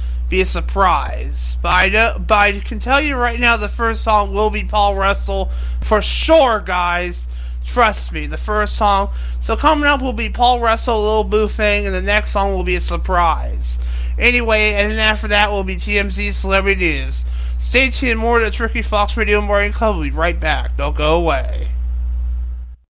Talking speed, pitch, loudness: 190 wpm, 195 Hz, -16 LUFS